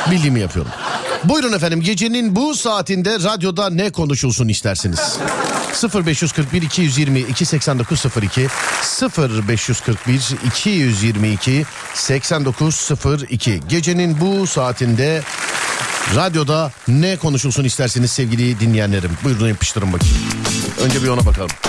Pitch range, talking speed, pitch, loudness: 120-170 Hz, 90 wpm, 135 Hz, -17 LUFS